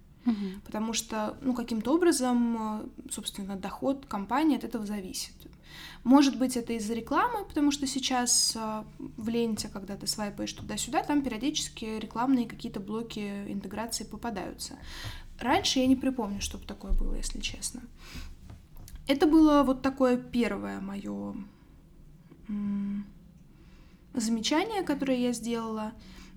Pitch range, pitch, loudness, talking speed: 210-265 Hz, 230 Hz, -29 LUFS, 115 wpm